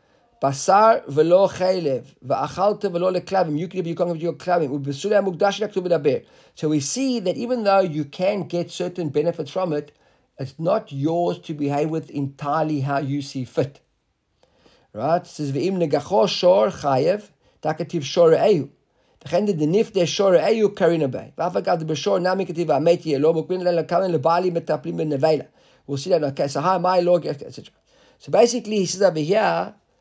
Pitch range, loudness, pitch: 155-185 Hz, -21 LUFS, 170 Hz